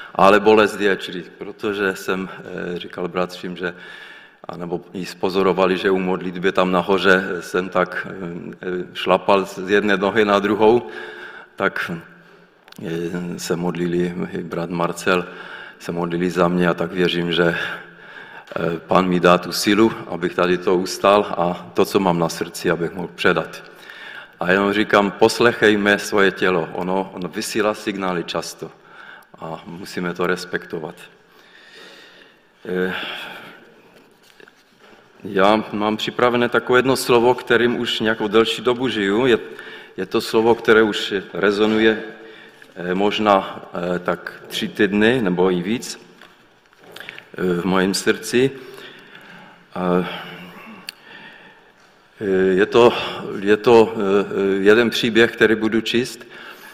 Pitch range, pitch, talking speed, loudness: 90-110 Hz, 95 Hz, 110 wpm, -19 LUFS